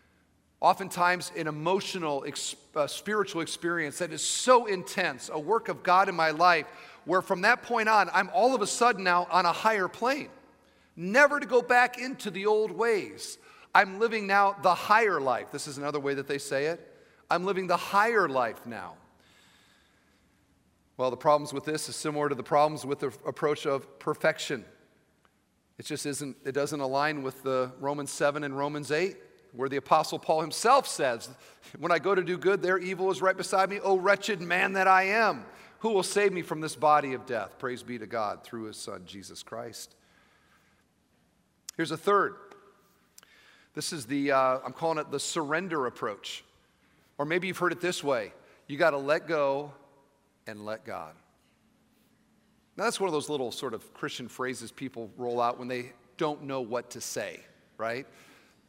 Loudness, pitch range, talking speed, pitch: -28 LUFS, 140-190 Hz, 185 wpm, 155 Hz